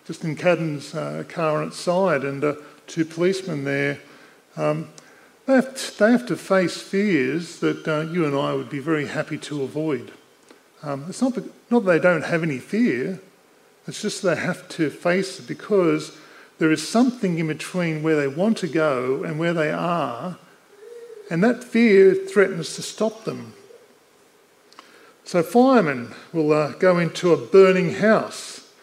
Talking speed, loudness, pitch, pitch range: 170 wpm, -22 LUFS, 175 Hz, 155-205 Hz